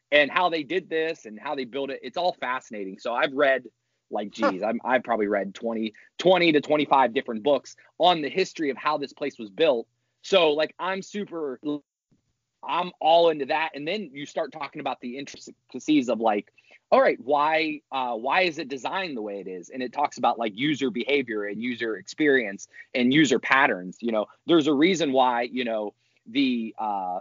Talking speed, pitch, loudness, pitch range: 200 wpm, 140 Hz, -25 LUFS, 120-160 Hz